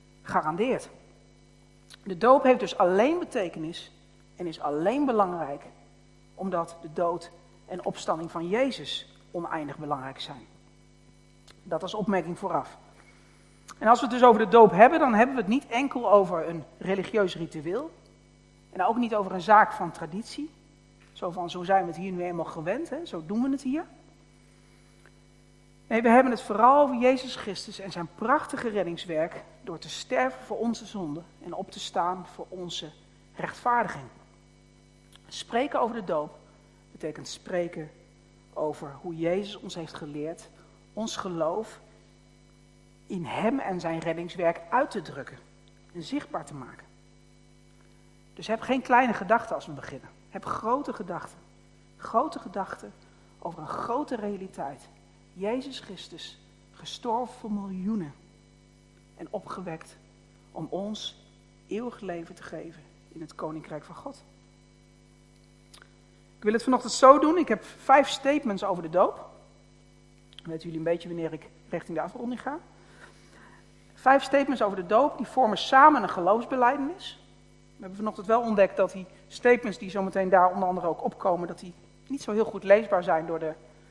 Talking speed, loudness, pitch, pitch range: 150 wpm, -26 LUFS, 195 Hz, 170-235 Hz